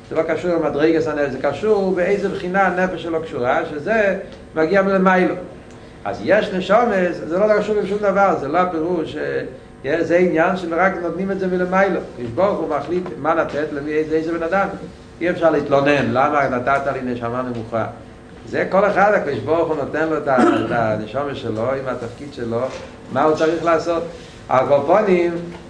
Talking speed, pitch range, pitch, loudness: 155 wpm, 145-185 Hz, 165 Hz, -19 LUFS